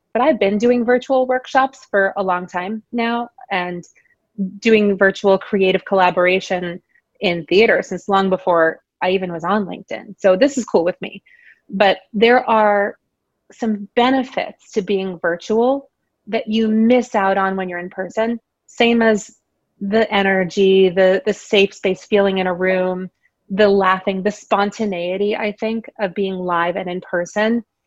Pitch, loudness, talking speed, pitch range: 200 Hz, -17 LUFS, 155 wpm, 185-225 Hz